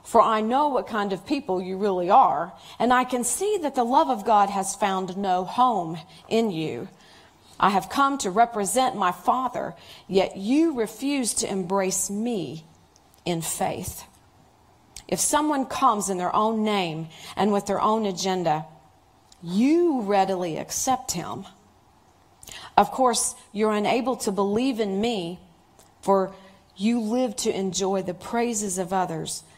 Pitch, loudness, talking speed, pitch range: 205 Hz, -24 LUFS, 150 wpm, 190-245 Hz